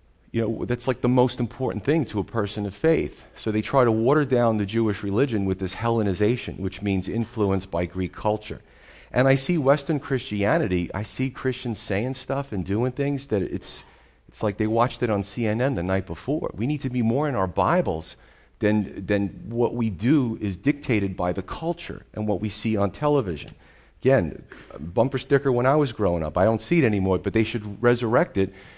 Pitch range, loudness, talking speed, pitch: 100-130 Hz, -24 LUFS, 205 wpm, 110 Hz